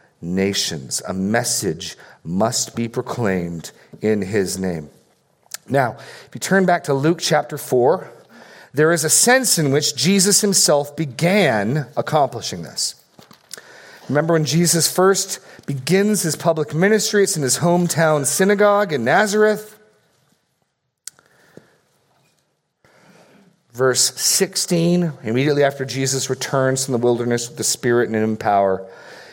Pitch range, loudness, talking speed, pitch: 120-180 Hz, -18 LUFS, 120 wpm, 150 Hz